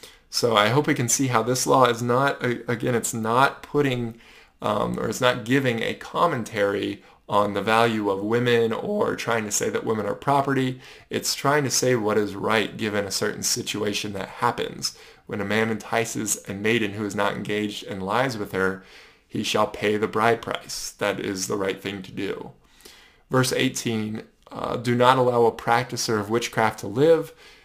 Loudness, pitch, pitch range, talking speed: -23 LUFS, 115 Hz, 105-125 Hz, 190 wpm